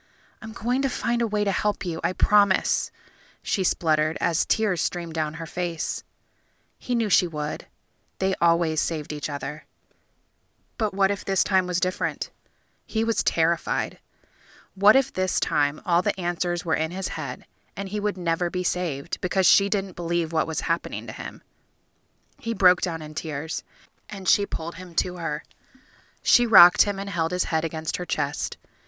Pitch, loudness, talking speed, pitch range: 180 Hz, -23 LUFS, 175 wpm, 165-200 Hz